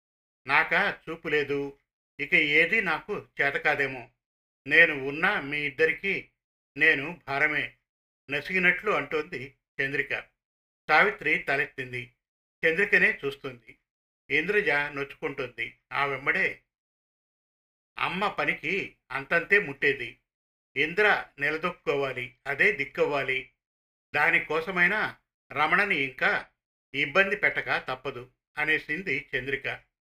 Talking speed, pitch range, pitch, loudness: 80 wpm, 130-165 Hz, 140 Hz, -26 LUFS